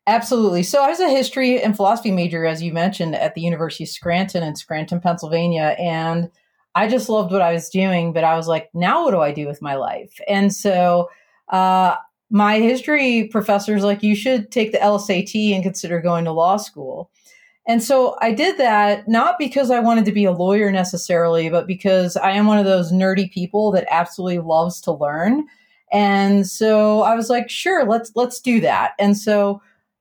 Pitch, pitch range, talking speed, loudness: 195 Hz, 175-225 Hz, 195 wpm, -18 LUFS